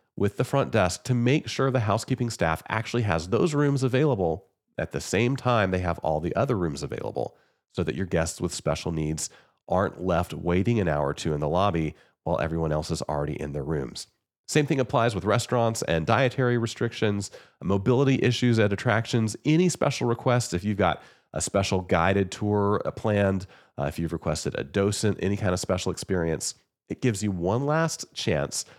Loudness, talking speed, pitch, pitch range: -26 LUFS, 190 wpm, 100 Hz, 85-120 Hz